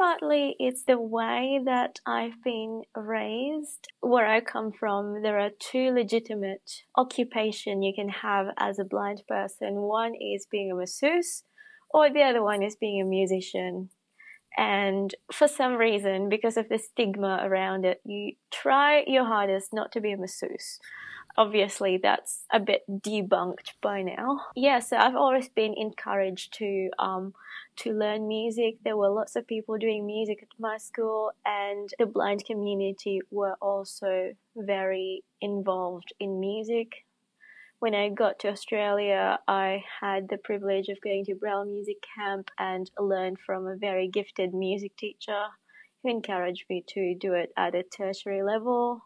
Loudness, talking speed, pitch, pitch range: -28 LUFS, 155 wpm, 210 Hz, 195-230 Hz